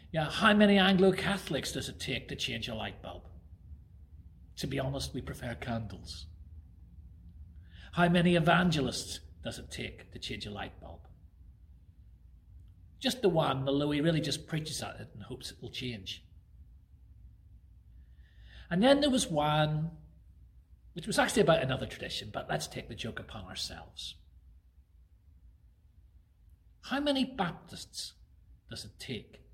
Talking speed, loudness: 140 wpm, -31 LUFS